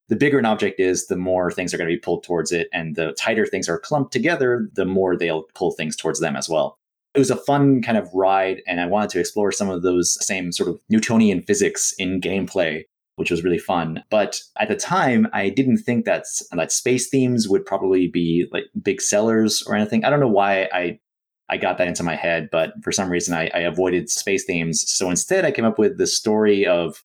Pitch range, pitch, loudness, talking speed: 90-115 Hz, 95 Hz, -20 LUFS, 235 wpm